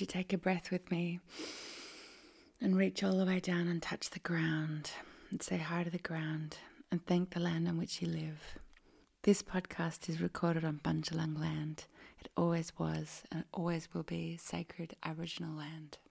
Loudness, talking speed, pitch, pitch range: -38 LUFS, 170 wpm, 170 Hz, 160-185 Hz